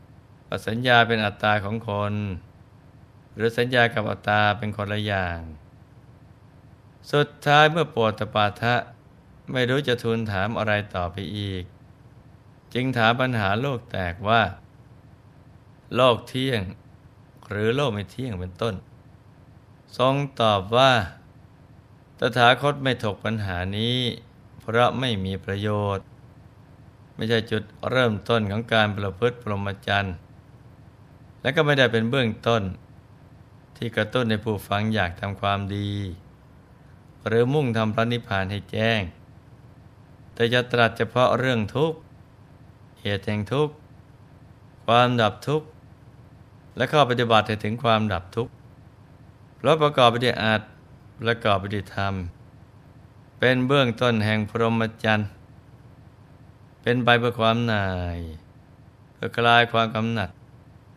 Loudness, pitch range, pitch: -23 LUFS, 105-125 Hz, 115 Hz